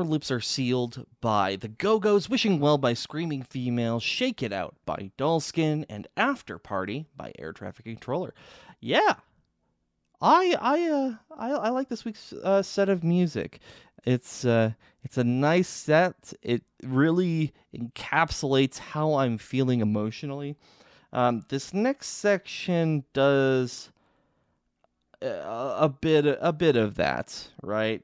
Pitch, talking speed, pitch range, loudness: 140 Hz, 135 wpm, 120-180 Hz, -26 LUFS